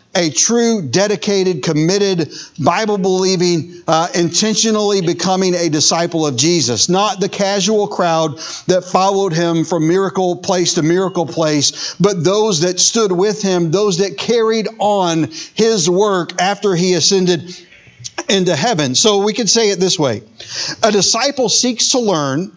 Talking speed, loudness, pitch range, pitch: 145 wpm, -14 LUFS, 170-205 Hz, 185 Hz